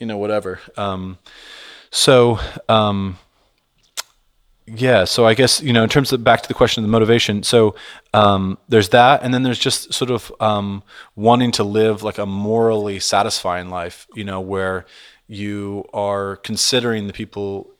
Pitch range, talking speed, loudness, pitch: 100-115 Hz, 165 wpm, -17 LUFS, 105 Hz